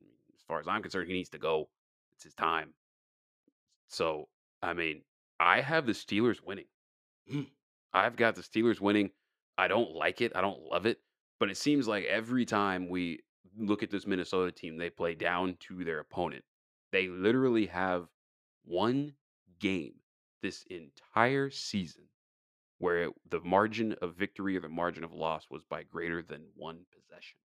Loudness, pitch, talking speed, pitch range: -33 LUFS, 95 Hz, 165 wpm, 85-110 Hz